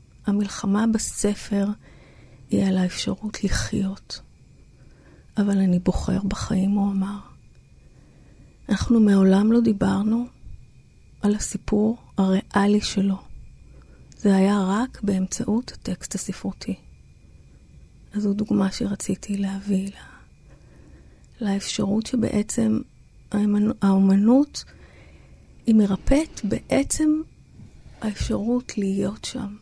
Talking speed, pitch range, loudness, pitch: 85 wpm, 190-215 Hz, -23 LUFS, 200 Hz